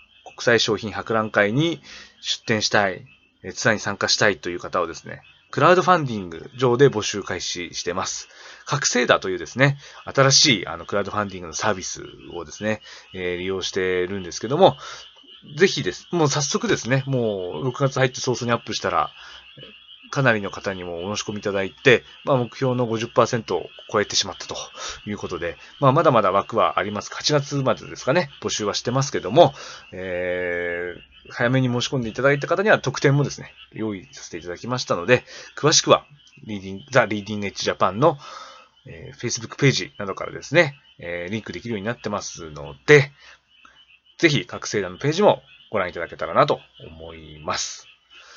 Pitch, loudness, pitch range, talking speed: 115 Hz, -21 LUFS, 95-135 Hz, 380 characters per minute